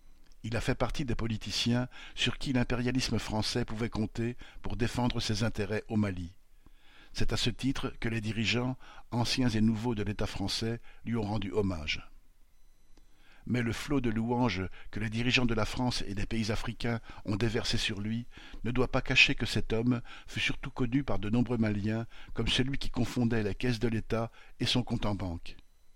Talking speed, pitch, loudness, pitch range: 185 wpm, 115 Hz, -32 LUFS, 105-125 Hz